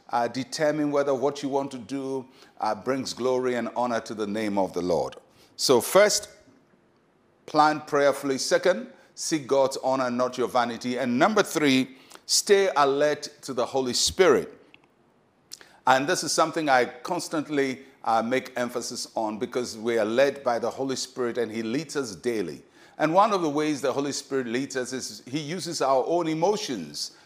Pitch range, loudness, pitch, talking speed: 125-150 Hz, -25 LUFS, 135 Hz, 170 wpm